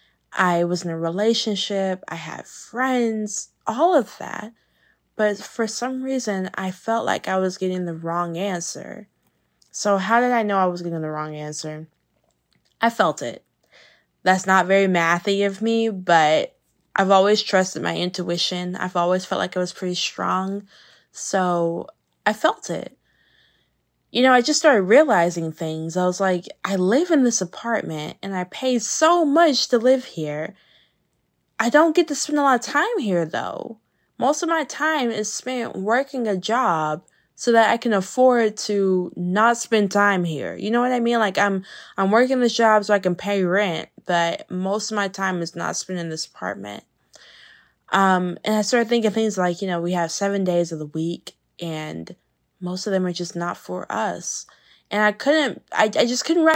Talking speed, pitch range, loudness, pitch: 185 wpm, 175-230 Hz, -21 LUFS, 195 Hz